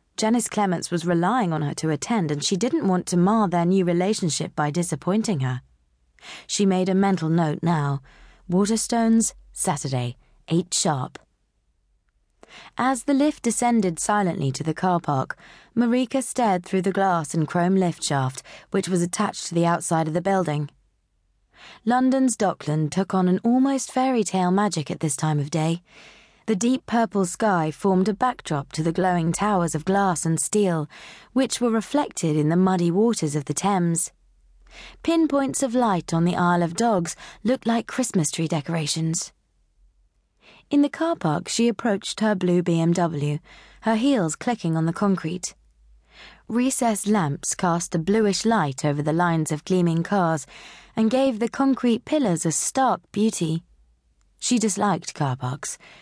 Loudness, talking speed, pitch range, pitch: -23 LUFS, 160 wpm, 160-220 Hz, 180 Hz